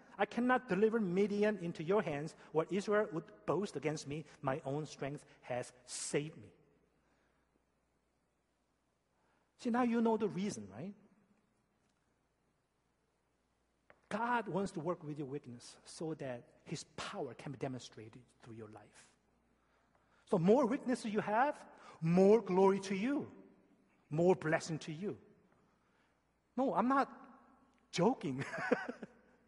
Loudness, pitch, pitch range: -36 LUFS, 190 Hz, 145-225 Hz